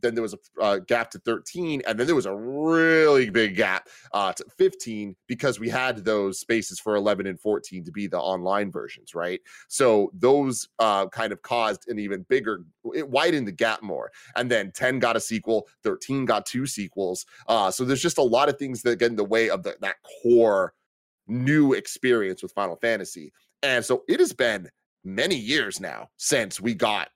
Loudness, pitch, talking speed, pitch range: -24 LUFS, 120 Hz, 200 wpm, 105-135 Hz